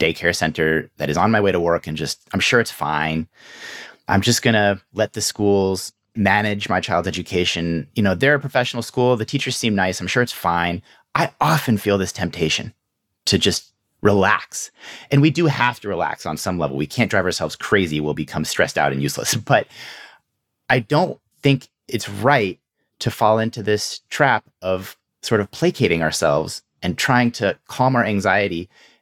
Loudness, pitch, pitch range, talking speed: -20 LUFS, 100 Hz, 85-120 Hz, 185 wpm